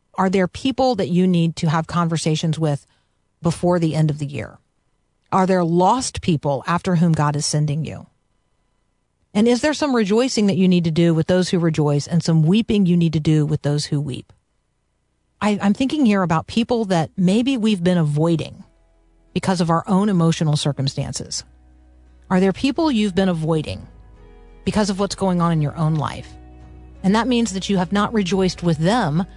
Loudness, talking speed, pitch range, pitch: -19 LUFS, 190 wpm, 150-195 Hz, 170 Hz